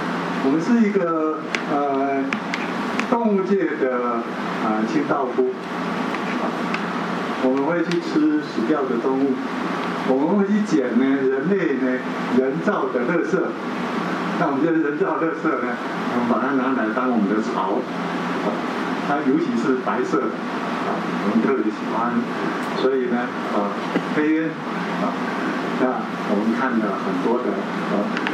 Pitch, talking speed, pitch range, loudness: 155 Hz, 190 characters per minute, 130-200 Hz, -22 LUFS